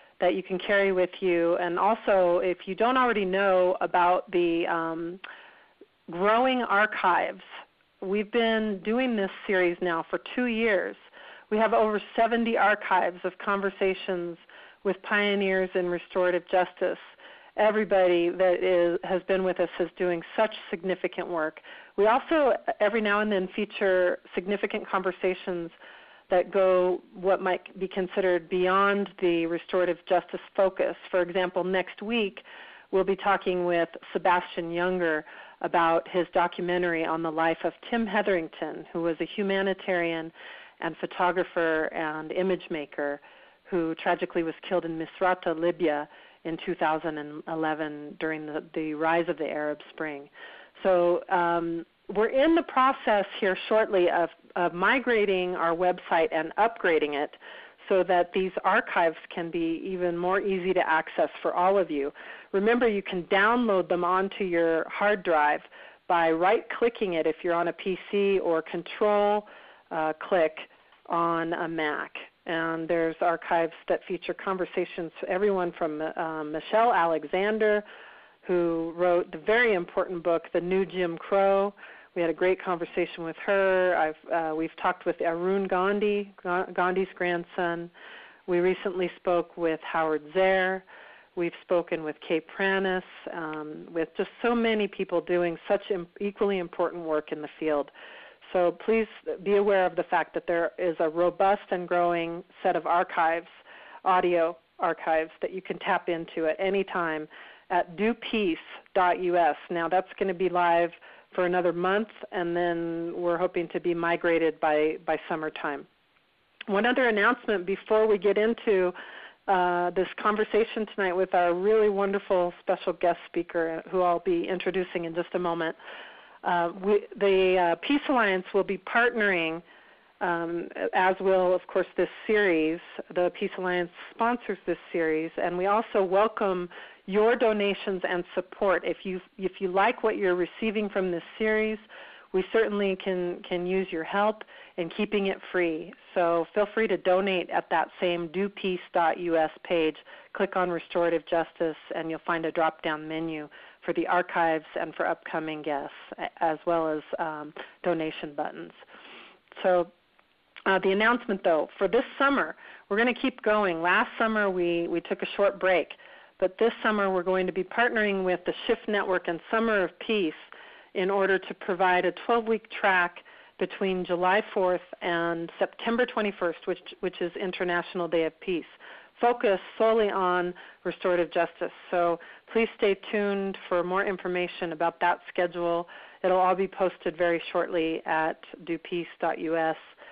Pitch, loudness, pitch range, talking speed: 180 Hz, -27 LUFS, 170-200 Hz, 150 wpm